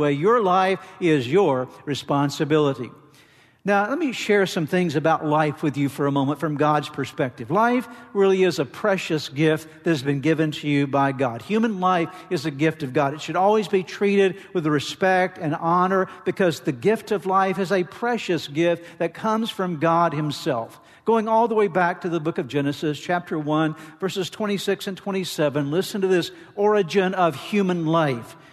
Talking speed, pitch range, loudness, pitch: 185 wpm, 150-190 Hz, -22 LUFS, 170 Hz